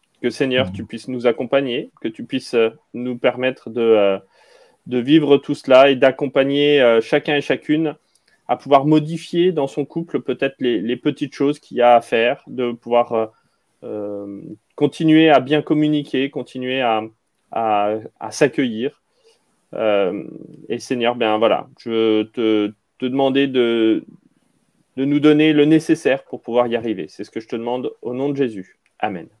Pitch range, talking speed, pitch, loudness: 115-145 Hz, 165 wpm, 130 Hz, -18 LUFS